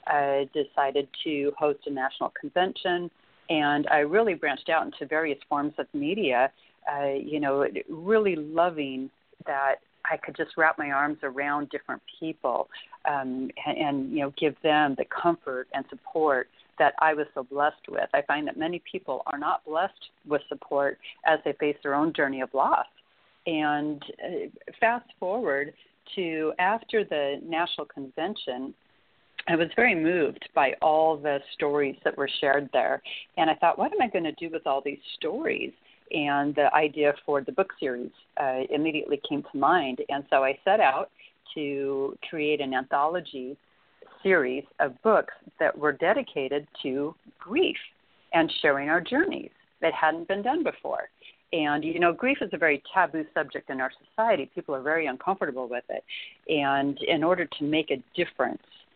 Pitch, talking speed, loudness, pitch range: 150 Hz, 165 wpm, -27 LUFS, 140-170 Hz